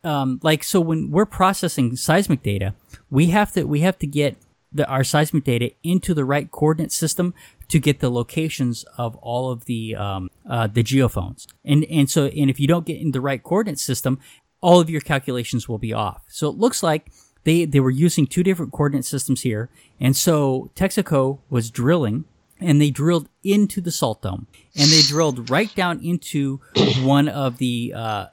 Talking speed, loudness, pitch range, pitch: 195 wpm, -20 LUFS, 125-165 Hz, 145 Hz